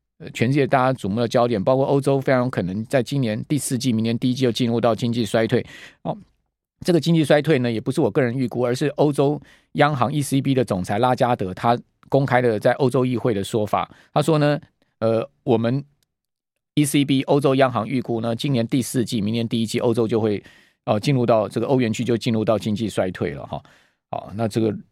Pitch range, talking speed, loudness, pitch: 115-135 Hz, 330 characters per minute, -21 LUFS, 125 Hz